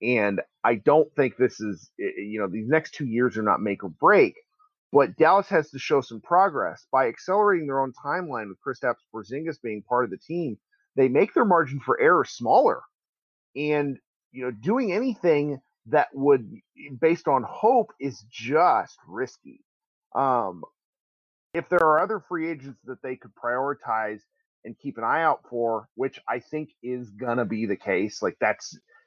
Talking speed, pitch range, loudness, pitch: 180 wpm, 120-170 Hz, -24 LUFS, 140 Hz